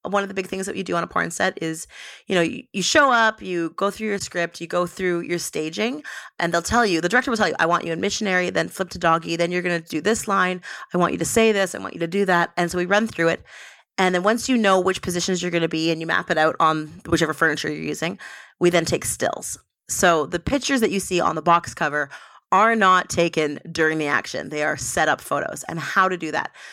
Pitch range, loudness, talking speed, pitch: 165-195 Hz, -21 LUFS, 275 wpm, 175 Hz